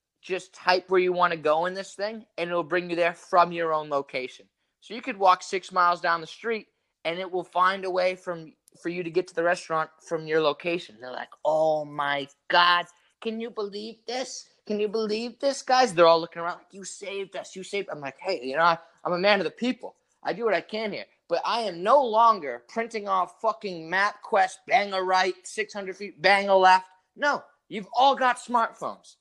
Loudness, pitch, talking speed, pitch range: -25 LUFS, 185 Hz, 225 wpm, 170-215 Hz